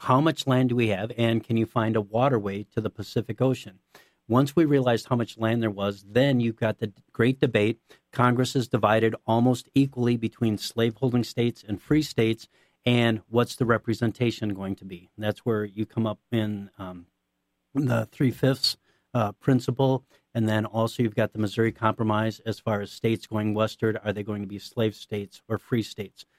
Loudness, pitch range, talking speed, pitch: -26 LUFS, 105-120 Hz, 190 wpm, 115 Hz